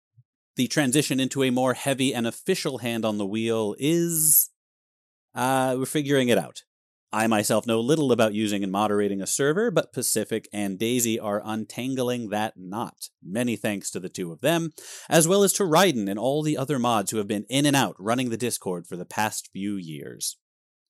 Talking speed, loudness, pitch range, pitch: 190 wpm, -24 LUFS, 105-135 Hz, 120 Hz